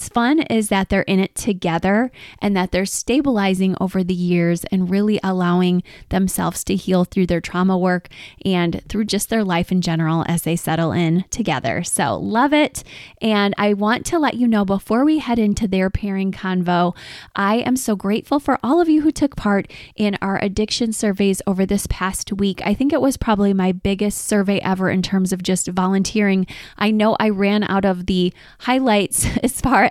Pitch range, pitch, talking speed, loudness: 185-215 Hz, 195 Hz, 195 wpm, -19 LUFS